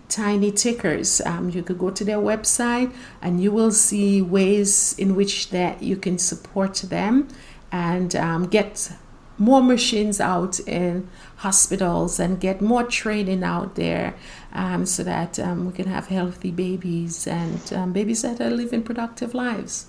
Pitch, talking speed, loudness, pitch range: 195 Hz, 155 wpm, -21 LUFS, 180-215 Hz